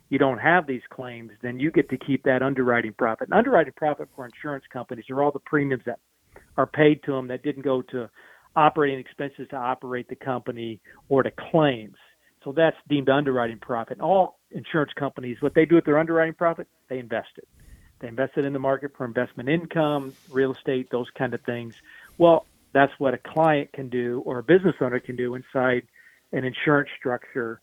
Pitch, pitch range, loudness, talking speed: 135 Hz, 125-145 Hz, -24 LUFS, 200 wpm